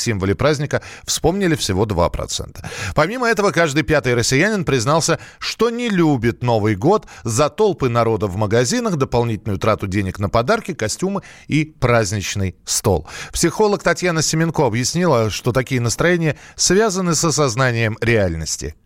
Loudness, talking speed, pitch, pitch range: -18 LUFS, 130 wpm, 130 Hz, 110-170 Hz